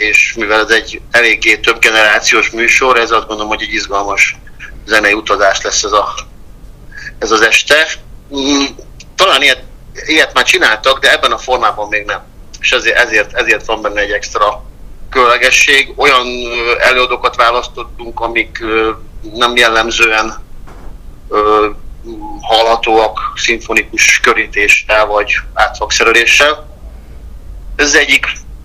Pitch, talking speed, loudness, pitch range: 110 Hz, 115 wpm, -10 LUFS, 105-120 Hz